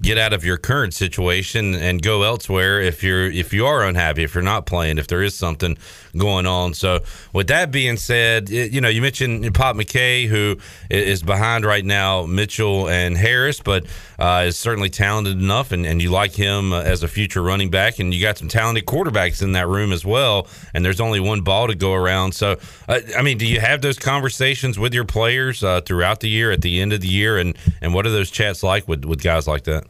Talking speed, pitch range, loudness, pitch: 230 wpm, 90-110 Hz, -18 LUFS, 100 Hz